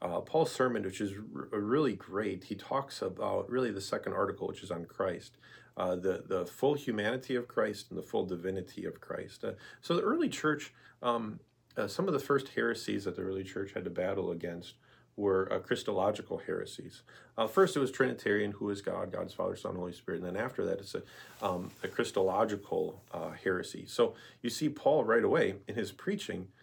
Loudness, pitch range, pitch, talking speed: -34 LUFS, 95-130 Hz, 105 Hz, 205 wpm